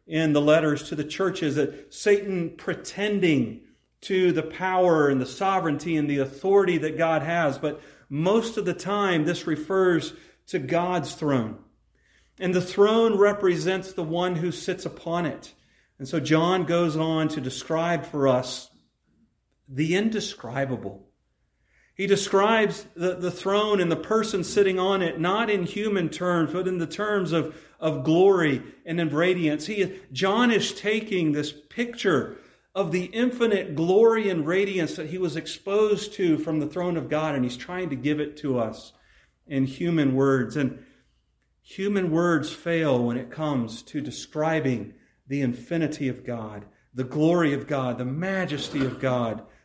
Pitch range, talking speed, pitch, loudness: 145-190 Hz, 160 wpm, 165 Hz, -25 LUFS